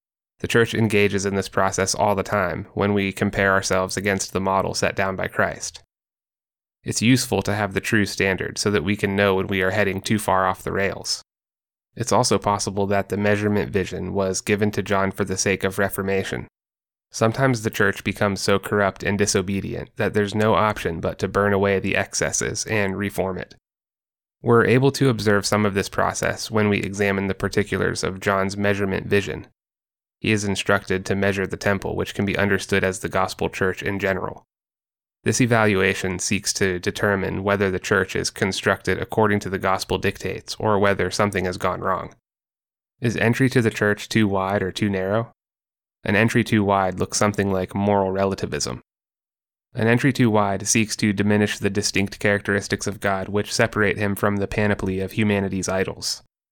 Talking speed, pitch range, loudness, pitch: 185 wpm, 95-105 Hz, -22 LUFS, 100 Hz